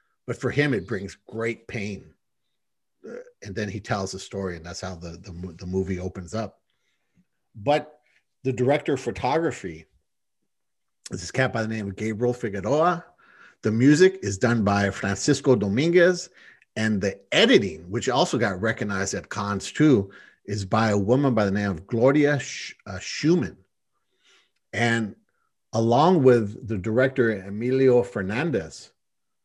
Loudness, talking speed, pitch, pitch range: -24 LUFS, 150 wpm, 115 Hz, 100-130 Hz